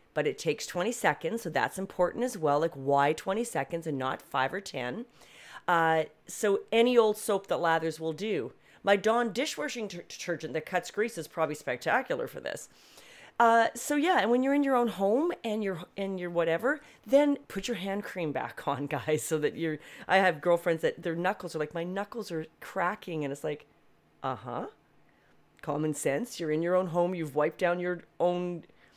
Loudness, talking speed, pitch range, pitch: -30 LUFS, 195 wpm, 160-220 Hz, 180 Hz